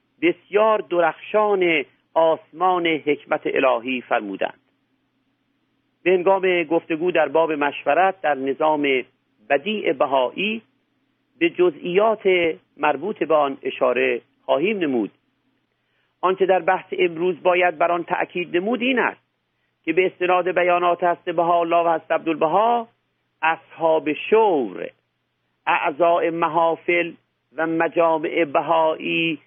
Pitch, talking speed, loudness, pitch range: 170 Hz, 105 wpm, -20 LUFS, 160-185 Hz